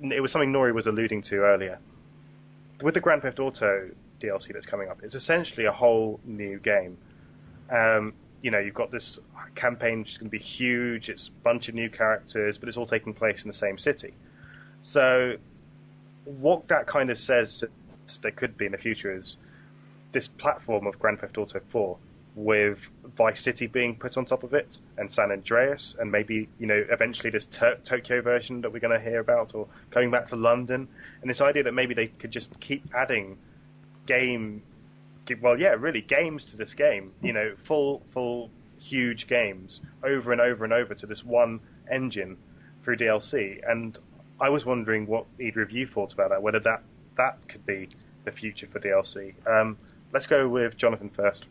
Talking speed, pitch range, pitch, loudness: 190 wpm, 110-130 Hz, 120 Hz, -27 LUFS